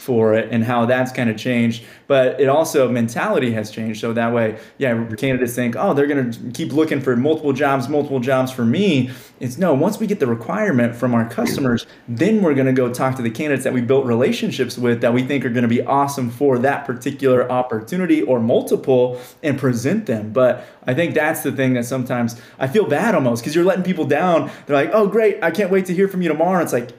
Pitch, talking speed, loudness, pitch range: 130 Hz, 225 wpm, -18 LUFS, 120-145 Hz